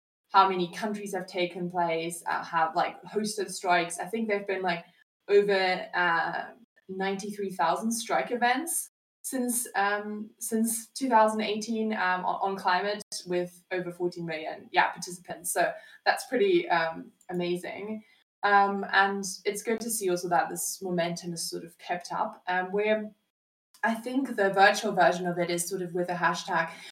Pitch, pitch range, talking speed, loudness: 195 Hz, 180-215 Hz, 165 wpm, -28 LUFS